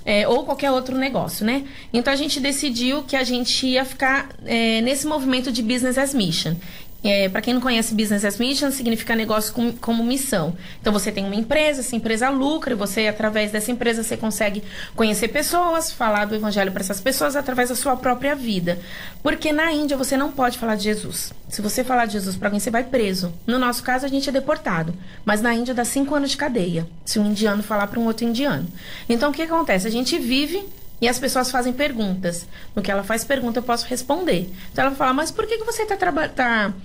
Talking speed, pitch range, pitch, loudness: 220 wpm, 210-275 Hz, 240 Hz, -21 LUFS